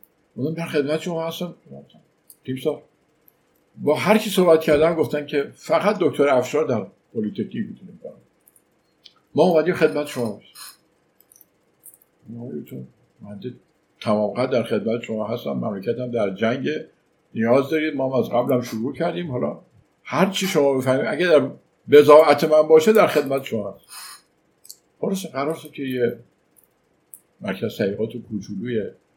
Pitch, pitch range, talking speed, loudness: 145 Hz, 120-160 Hz, 115 wpm, -21 LUFS